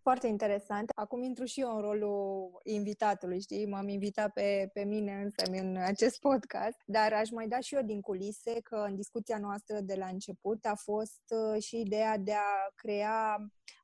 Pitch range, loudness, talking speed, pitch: 200-225 Hz, -34 LUFS, 180 wpm, 210 Hz